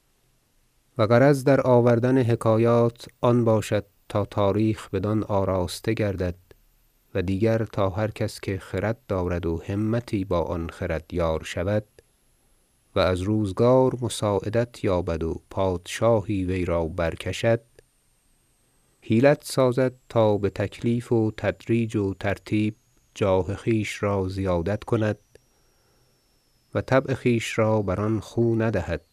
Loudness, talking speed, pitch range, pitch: -24 LUFS, 120 wpm, 95-120 Hz, 110 Hz